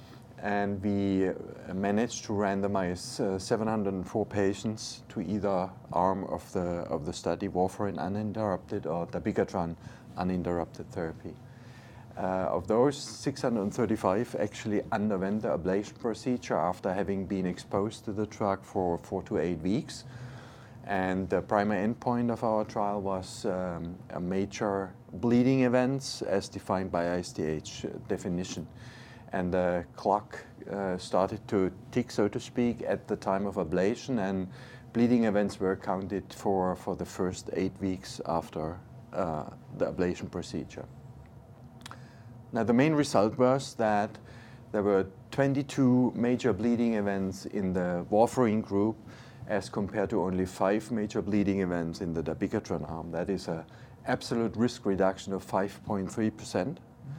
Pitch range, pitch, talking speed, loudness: 95-120 Hz, 100 Hz, 135 wpm, -31 LUFS